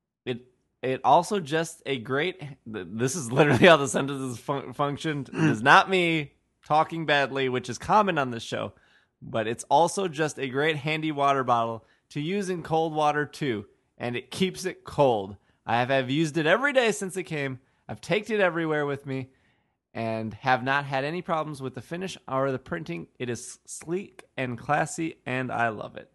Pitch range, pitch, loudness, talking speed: 130-165 Hz, 145 Hz, -26 LUFS, 190 wpm